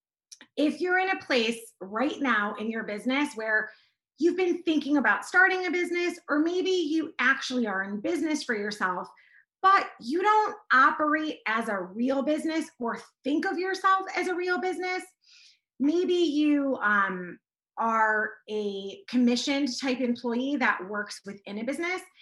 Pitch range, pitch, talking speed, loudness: 220-355 Hz, 280 Hz, 150 wpm, -27 LUFS